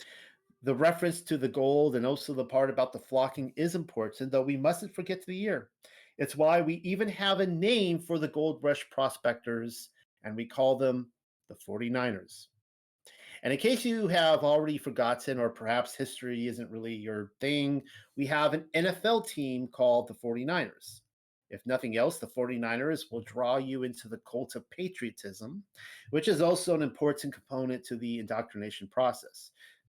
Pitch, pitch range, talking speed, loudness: 135 Hz, 120-160 Hz, 165 wpm, -31 LUFS